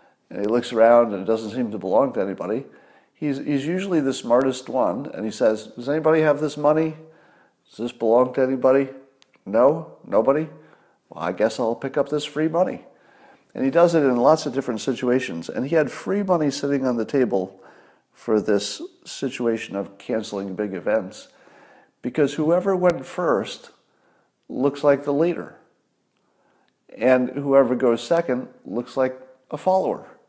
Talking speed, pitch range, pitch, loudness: 165 wpm, 120-150 Hz, 135 Hz, -22 LUFS